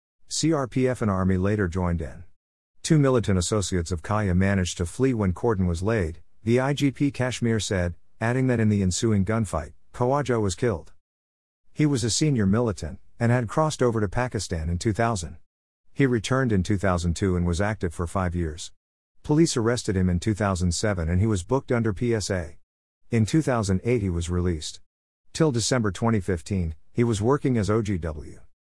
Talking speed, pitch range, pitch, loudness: 165 wpm, 90-120 Hz, 100 Hz, -25 LUFS